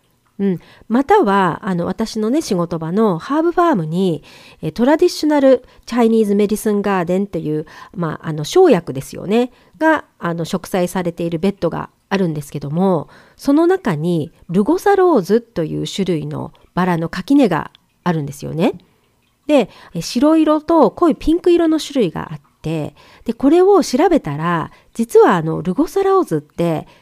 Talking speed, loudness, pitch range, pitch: 325 characters per minute, -16 LUFS, 170-280 Hz, 195 Hz